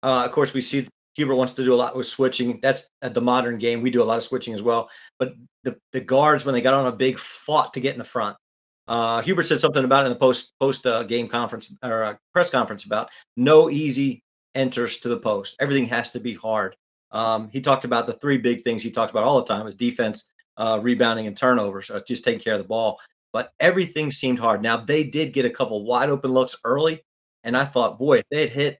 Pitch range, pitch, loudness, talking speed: 120-135 Hz, 125 Hz, -22 LUFS, 245 wpm